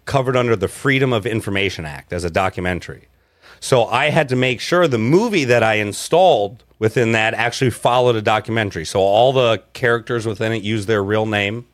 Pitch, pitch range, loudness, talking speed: 115 Hz, 100-125 Hz, -17 LUFS, 190 wpm